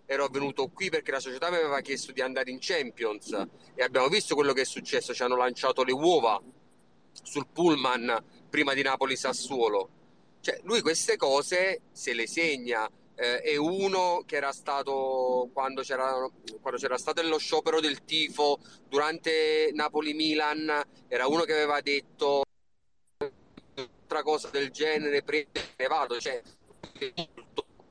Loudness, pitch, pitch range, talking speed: -29 LUFS, 145 Hz, 135-155 Hz, 145 wpm